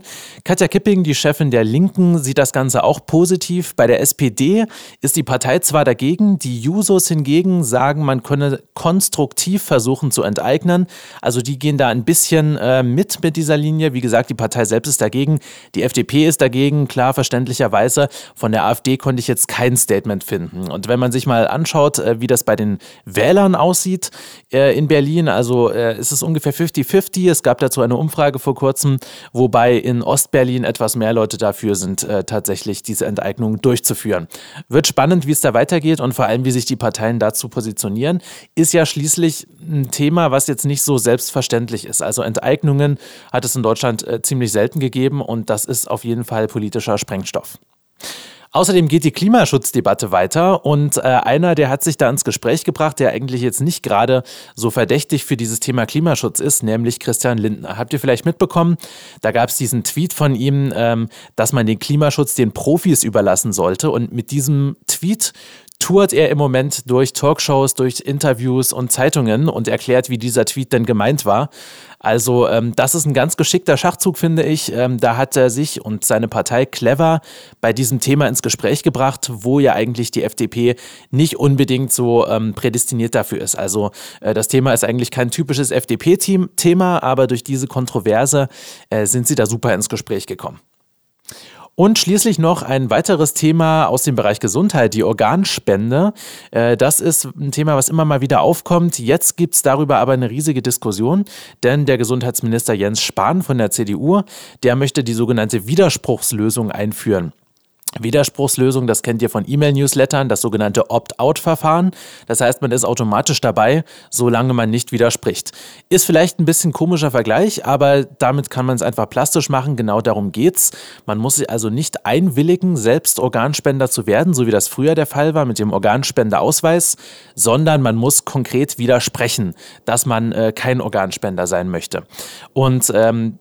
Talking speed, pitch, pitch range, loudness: 175 wpm, 135 Hz, 120-155 Hz, -16 LUFS